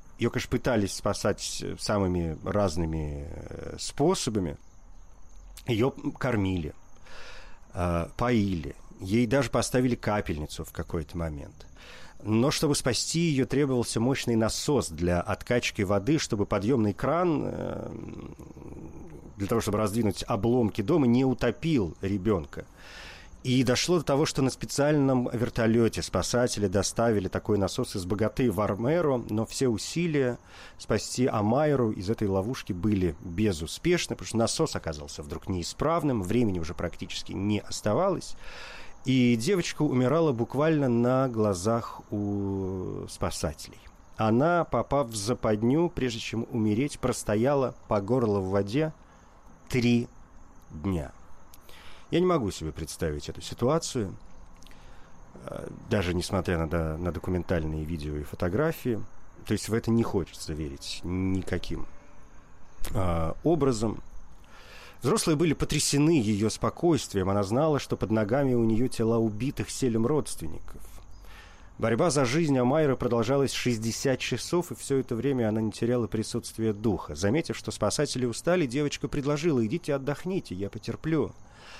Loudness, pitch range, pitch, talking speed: -28 LUFS, 90-130 Hz, 110 Hz, 120 wpm